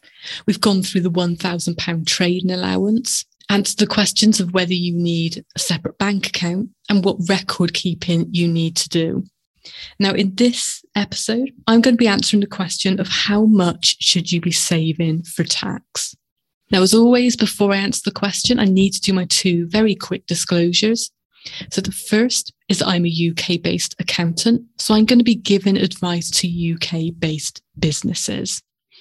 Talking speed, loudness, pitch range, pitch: 170 wpm, -18 LUFS, 170-210 Hz, 190 Hz